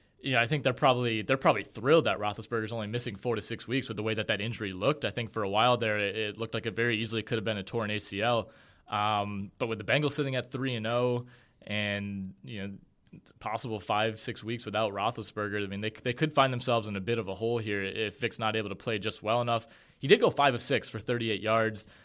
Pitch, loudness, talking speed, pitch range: 110 Hz, -30 LUFS, 260 wpm, 105-120 Hz